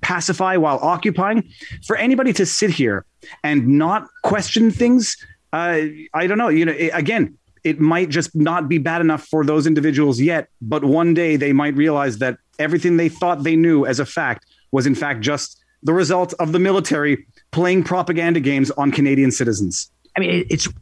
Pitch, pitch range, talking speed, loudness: 160 Hz, 145-180 Hz, 185 wpm, -18 LUFS